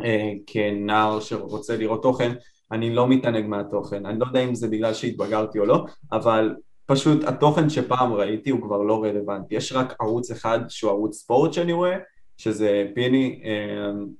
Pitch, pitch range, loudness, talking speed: 115 Hz, 105-125 Hz, -23 LUFS, 165 wpm